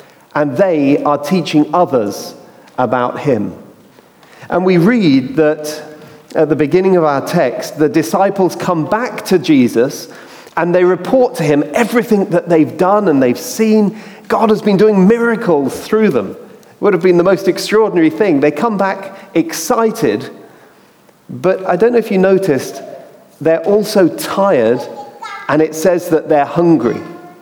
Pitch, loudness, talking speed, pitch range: 185 Hz, -13 LUFS, 155 wpm, 155-210 Hz